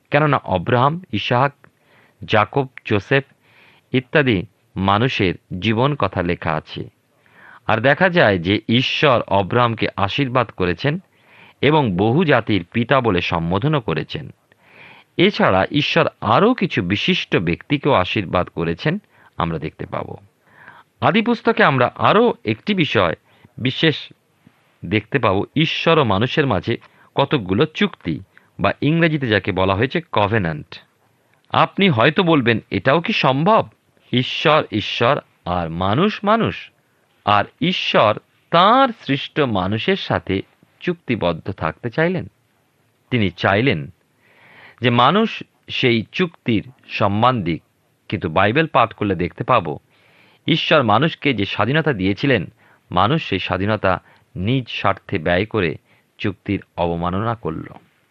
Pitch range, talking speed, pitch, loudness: 100-150 Hz, 110 wpm, 120 Hz, -18 LUFS